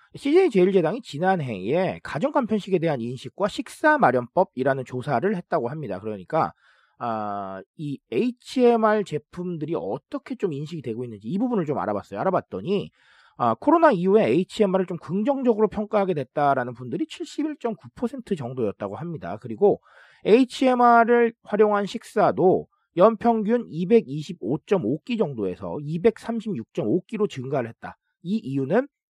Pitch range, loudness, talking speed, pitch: 140-235 Hz, -23 LUFS, 305 characters per minute, 195 Hz